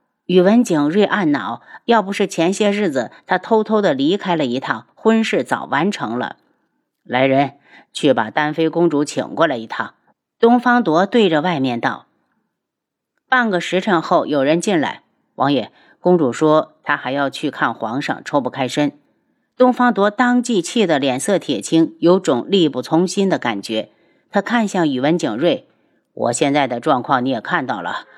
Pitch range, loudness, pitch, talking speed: 150-235 Hz, -17 LUFS, 185 Hz, 240 characters per minute